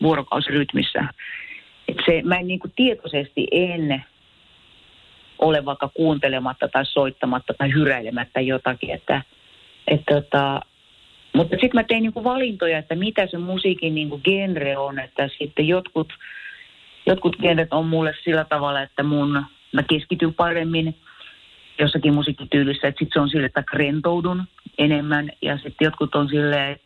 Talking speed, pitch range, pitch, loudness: 140 wpm, 140-175 Hz, 155 Hz, -21 LUFS